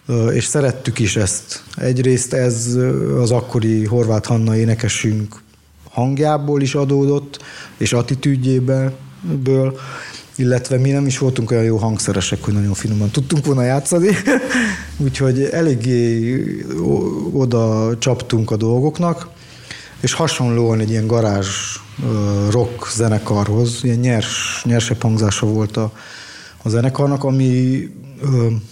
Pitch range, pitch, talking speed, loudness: 110-135 Hz, 120 Hz, 105 wpm, -17 LUFS